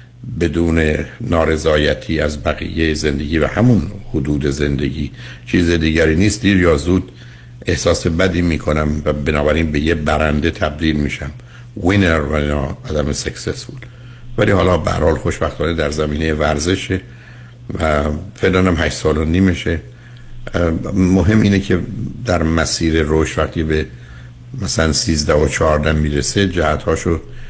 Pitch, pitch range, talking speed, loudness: 80 Hz, 75-100 Hz, 125 wpm, -16 LUFS